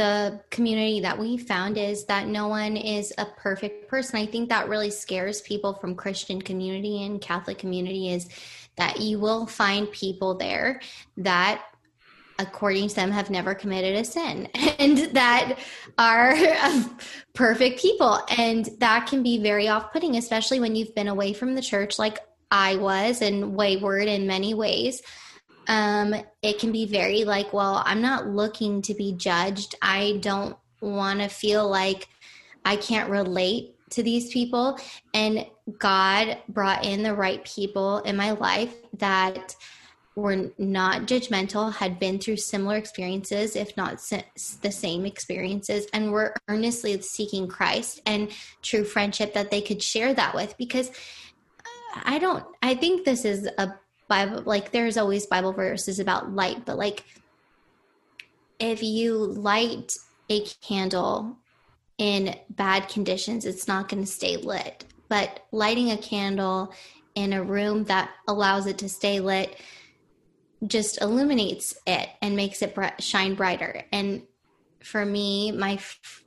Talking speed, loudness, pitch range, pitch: 150 wpm, -25 LUFS, 195-225 Hz, 205 Hz